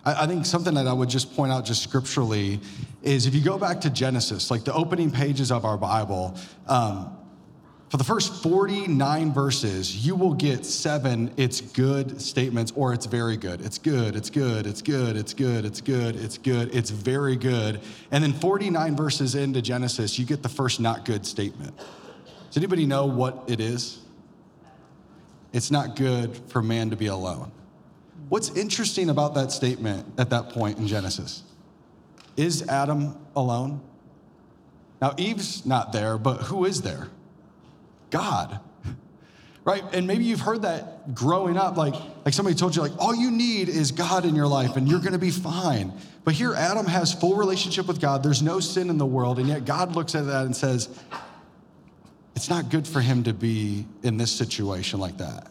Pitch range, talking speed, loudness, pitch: 115-160 Hz, 185 wpm, -25 LUFS, 135 Hz